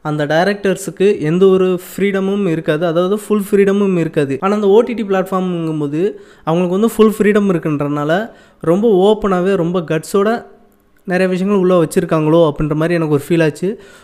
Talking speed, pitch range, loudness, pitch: 140 wpm, 160-200 Hz, -14 LUFS, 185 Hz